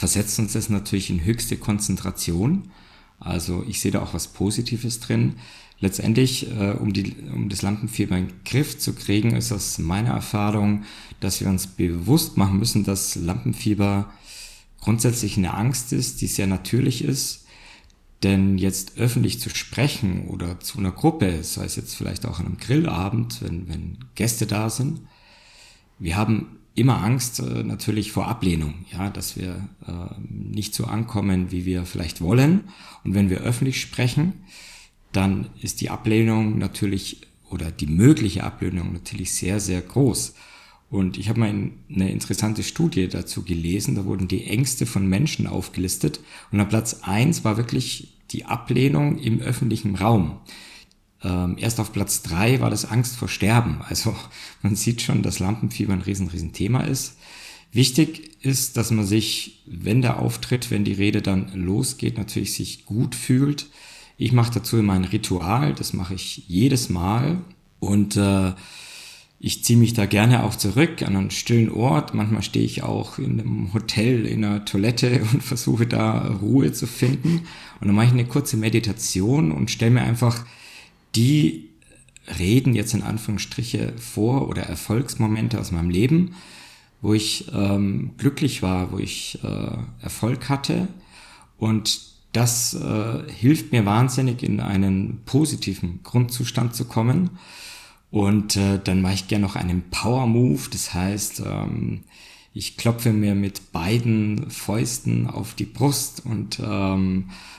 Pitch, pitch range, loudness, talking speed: 105 Hz, 95-125 Hz, -23 LUFS, 155 wpm